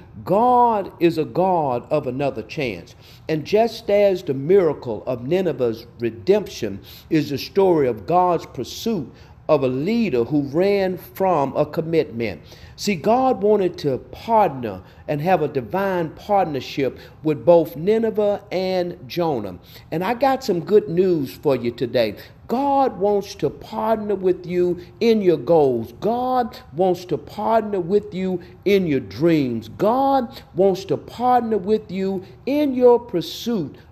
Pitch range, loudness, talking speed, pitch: 140-205 Hz, -21 LUFS, 140 wpm, 180 Hz